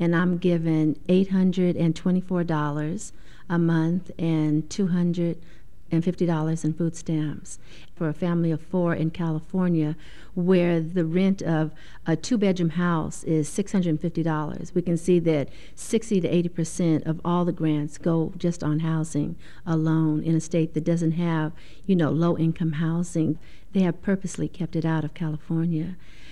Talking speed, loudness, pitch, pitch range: 140 wpm, -25 LUFS, 165 Hz, 160-175 Hz